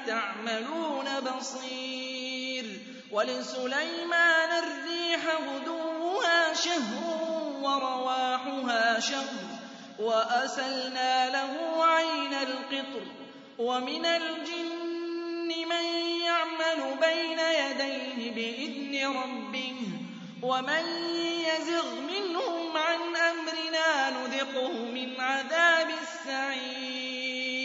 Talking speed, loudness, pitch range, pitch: 65 wpm, -29 LUFS, 260-330 Hz, 275 Hz